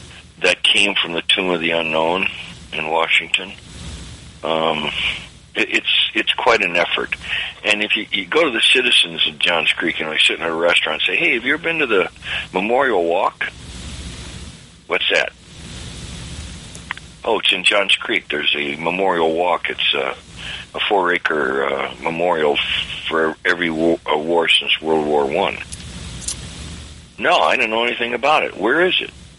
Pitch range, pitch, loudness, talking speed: 75-85 Hz, 80 Hz, -17 LUFS, 165 wpm